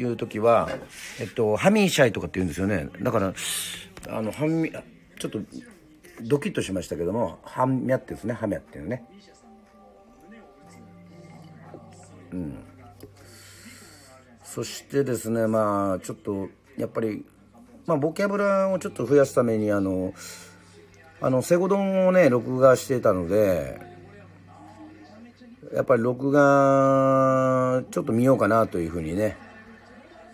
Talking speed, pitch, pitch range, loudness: 270 characters per minute, 115 Hz, 95-135 Hz, -24 LUFS